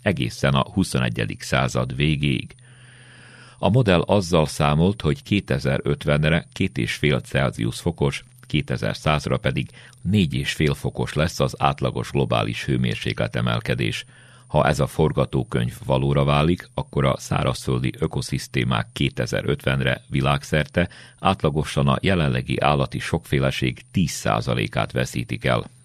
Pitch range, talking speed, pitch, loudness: 65-85 Hz, 100 wpm, 70 Hz, -22 LUFS